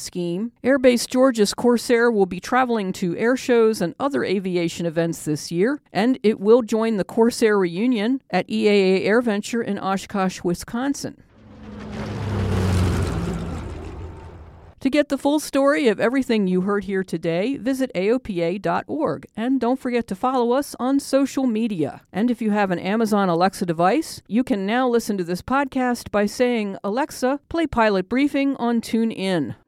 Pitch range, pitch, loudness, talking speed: 180-250 Hz, 220 Hz, -21 LUFS, 150 wpm